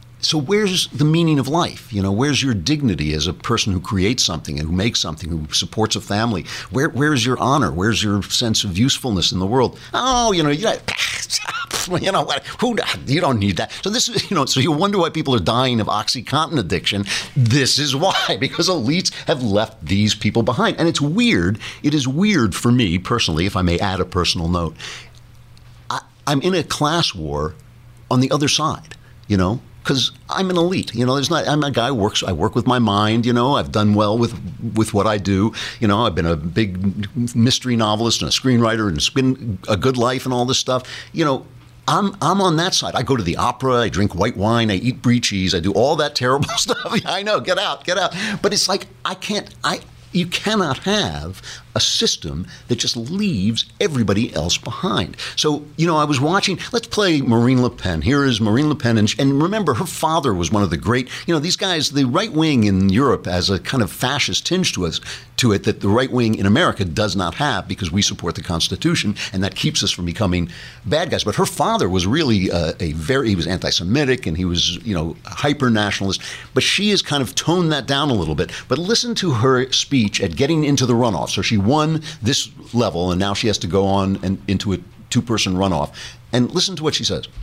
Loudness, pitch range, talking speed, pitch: -18 LUFS, 100-150 Hz, 225 wpm, 120 Hz